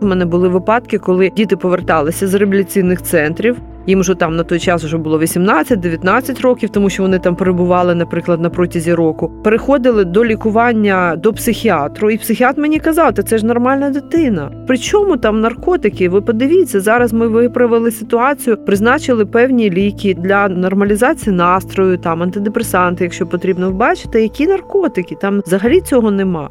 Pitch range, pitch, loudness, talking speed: 180-235 Hz, 205 Hz, -13 LUFS, 160 wpm